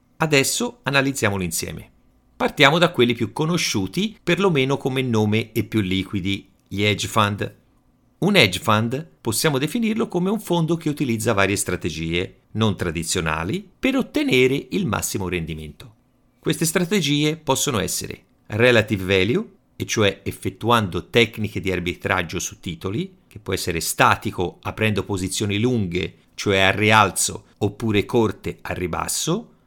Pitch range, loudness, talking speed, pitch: 95-135 Hz, -21 LUFS, 130 wpm, 110 Hz